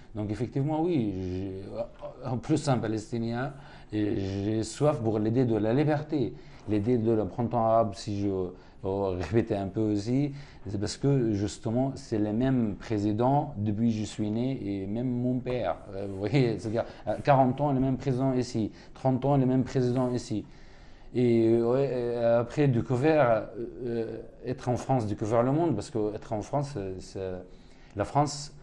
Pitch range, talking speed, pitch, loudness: 105-130 Hz, 160 wpm, 115 Hz, -29 LUFS